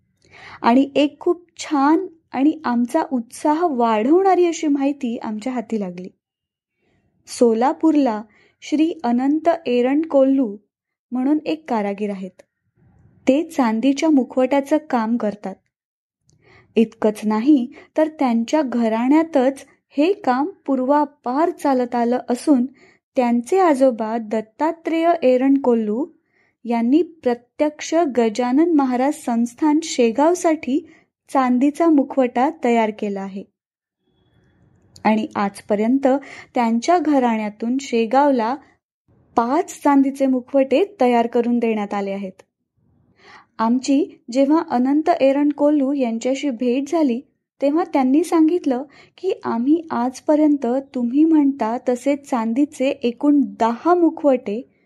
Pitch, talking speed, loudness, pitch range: 270 Hz, 95 wpm, -19 LUFS, 240-305 Hz